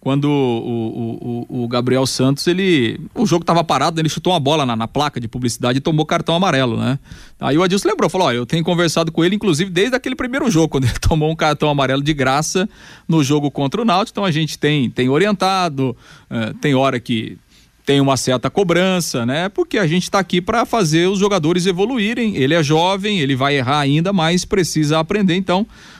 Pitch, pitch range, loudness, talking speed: 160 Hz, 135-185 Hz, -17 LUFS, 210 wpm